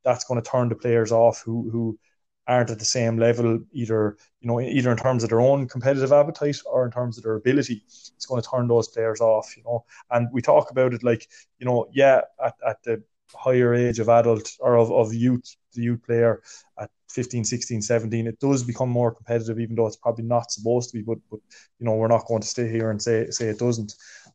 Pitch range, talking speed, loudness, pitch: 115-125 Hz, 235 wpm, -23 LUFS, 120 Hz